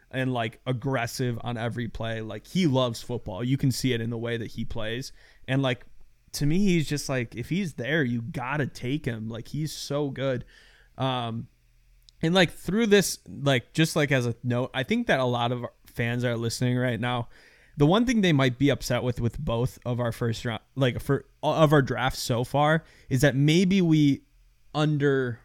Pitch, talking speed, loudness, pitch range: 125 Hz, 205 wpm, -26 LUFS, 120-145 Hz